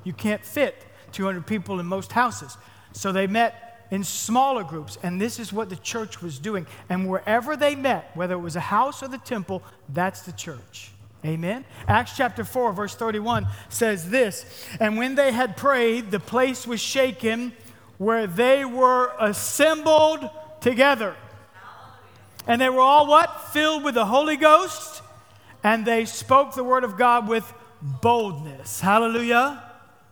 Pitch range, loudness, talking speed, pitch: 190-260 Hz, -22 LUFS, 155 wpm, 230 Hz